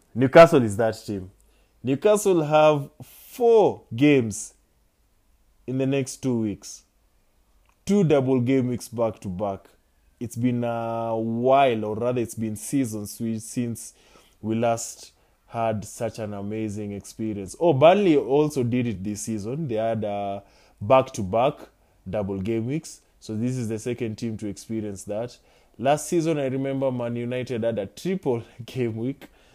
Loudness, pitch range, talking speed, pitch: -24 LUFS, 105-130 Hz, 150 wpm, 115 Hz